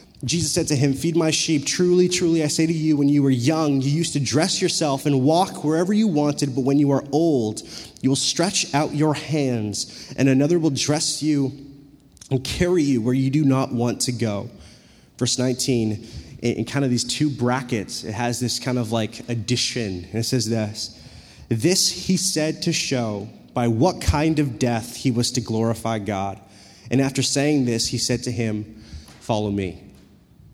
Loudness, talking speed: -21 LUFS, 190 wpm